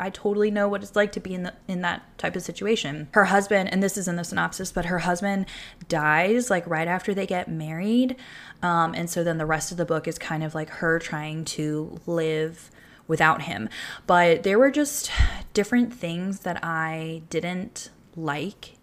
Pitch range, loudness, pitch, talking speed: 160-200 Hz, -25 LUFS, 175 Hz, 200 wpm